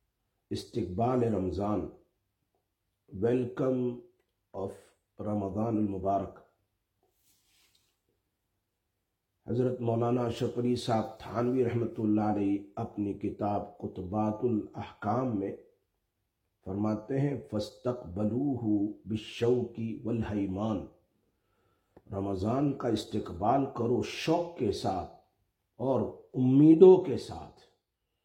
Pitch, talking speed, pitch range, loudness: 110 Hz, 75 wpm, 100-120 Hz, -30 LUFS